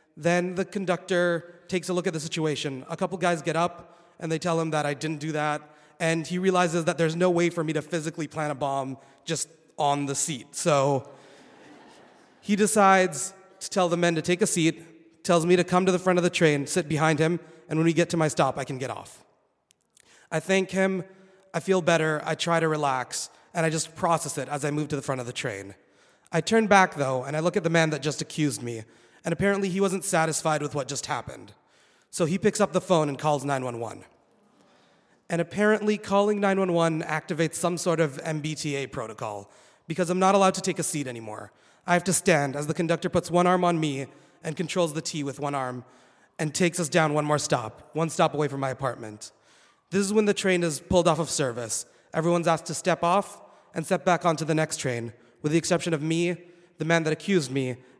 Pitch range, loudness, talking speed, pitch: 150-180 Hz, -26 LUFS, 220 wpm, 165 Hz